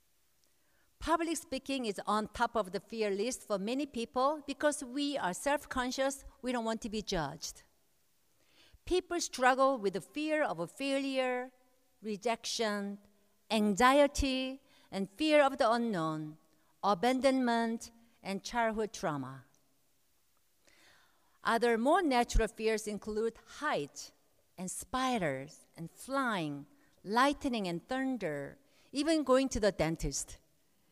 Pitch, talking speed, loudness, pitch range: 230 Hz, 115 wpm, -33 LUFS, 200-270 Hz